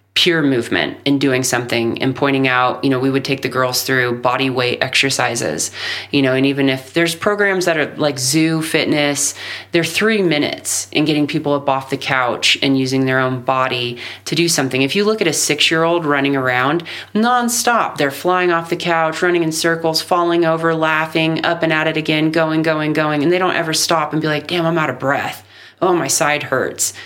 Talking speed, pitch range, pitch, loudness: 210 wpm, 135-165 Hz, 150 Hz, -16 LUFS